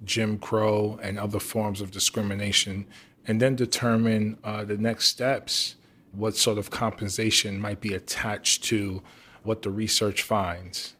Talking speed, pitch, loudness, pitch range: 140 wpm, 105 Hz, -26 LUFS, 100-110 Hz